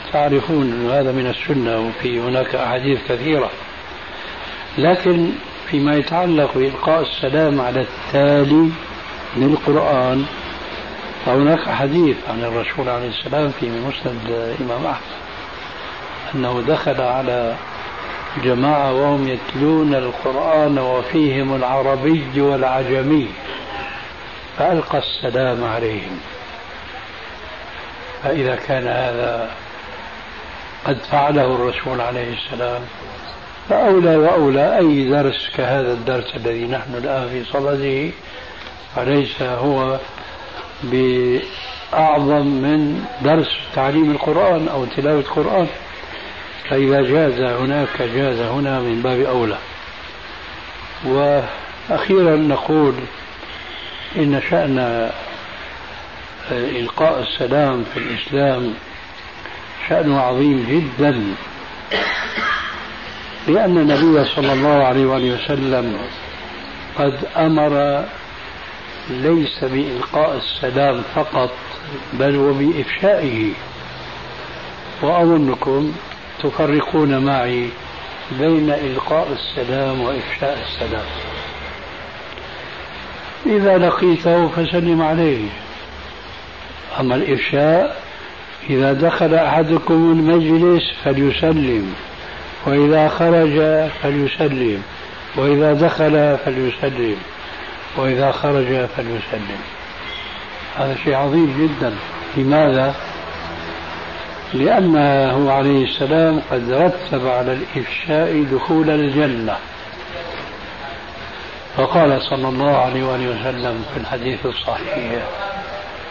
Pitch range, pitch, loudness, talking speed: 125-150 Hz, 135 Hz, -17 LUFS, 80 wpm